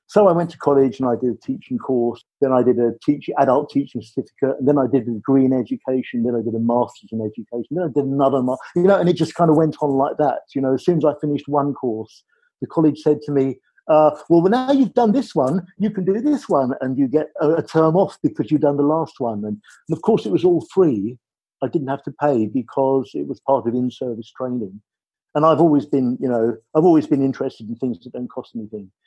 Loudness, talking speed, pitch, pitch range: -19 LUFS, 250 wpm, 140 Hz, 125-160 Hz